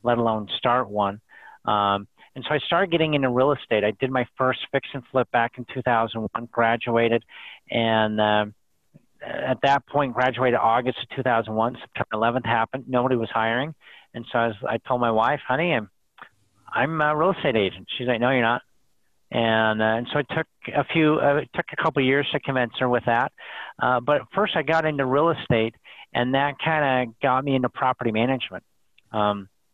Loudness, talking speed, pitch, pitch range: -23 LUFS, 200 wpm, 125 Hz, 115-140 Hz